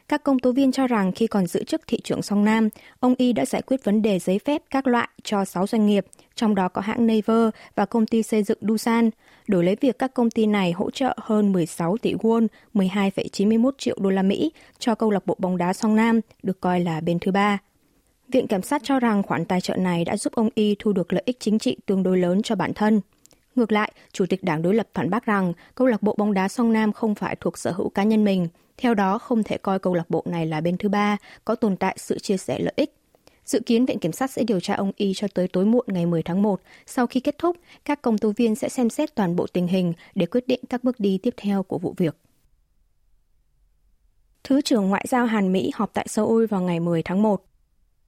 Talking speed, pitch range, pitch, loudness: 250 wpm, 185-230 Hz, 210 Hz, -23 LUFS